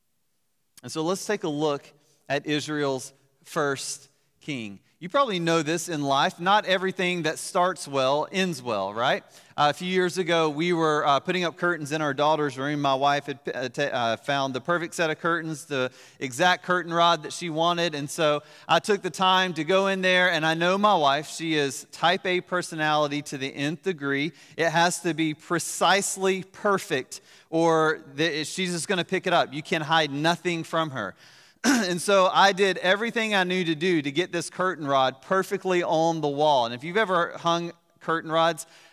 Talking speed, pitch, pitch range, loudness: 195 wpm, 165 Hz, 145-180 Hz, -25 LUFS